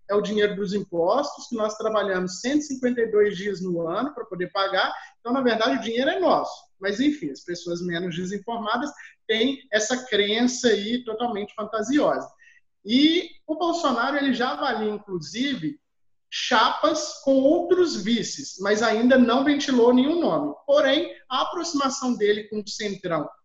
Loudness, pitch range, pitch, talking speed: -23 LUFS, 205-290 Hz, 240 Hz, 150 wpm